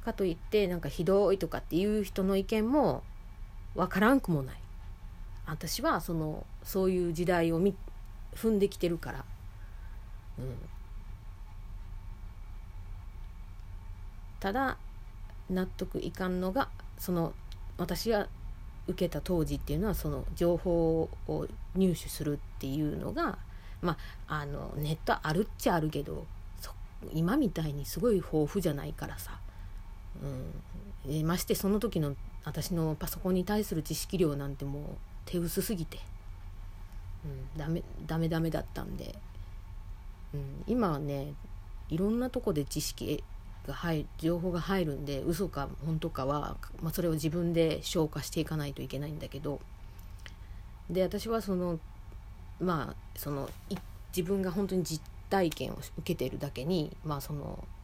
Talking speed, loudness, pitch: 265 characters per minute, -33 LUFS, 150 Hz